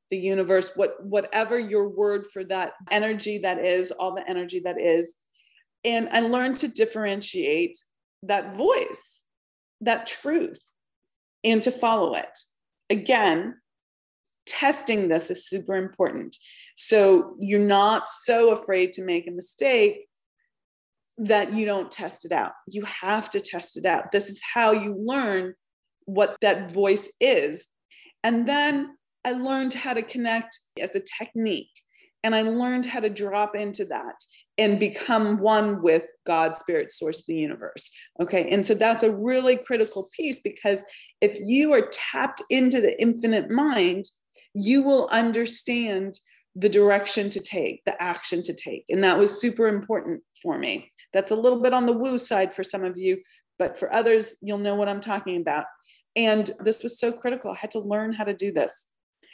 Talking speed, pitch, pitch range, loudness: 165 wpm, 215 Hz, 195-250 Hz, -24 LUFS